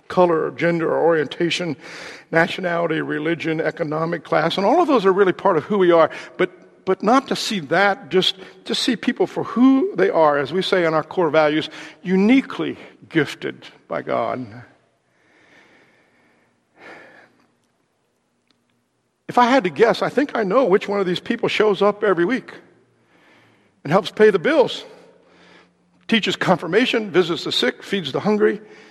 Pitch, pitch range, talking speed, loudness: 185 Hz, 165-215 Hz, 160 wpm, -19 LUFS